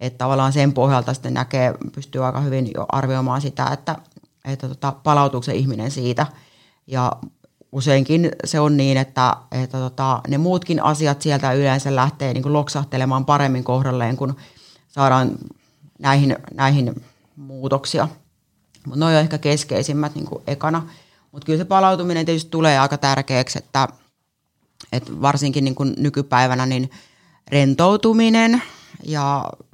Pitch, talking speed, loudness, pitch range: 140 Hz, 135 wpm, -19 LUFS, 130-150 Hz